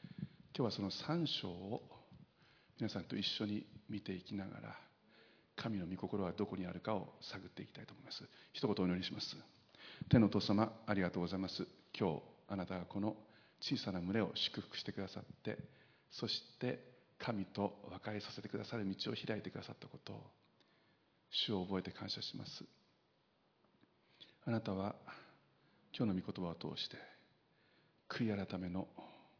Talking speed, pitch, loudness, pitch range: 300 characters per minute, 100 Hz, -42 LUFS, 95-110 Hz